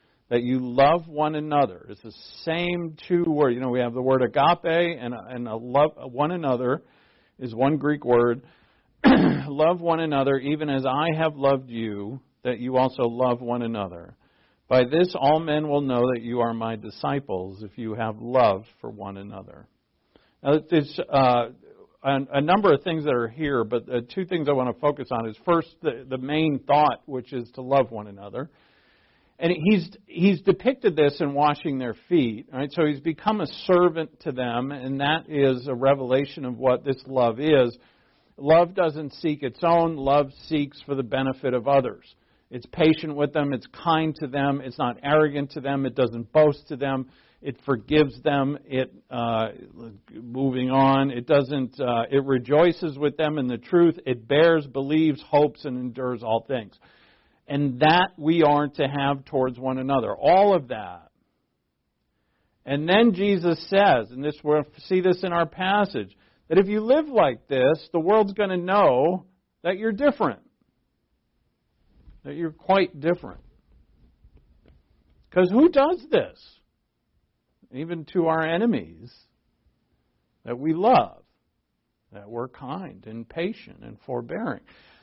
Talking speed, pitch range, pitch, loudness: 165 wpm, 125-160 Hz, 140 Hz, -23 LUFS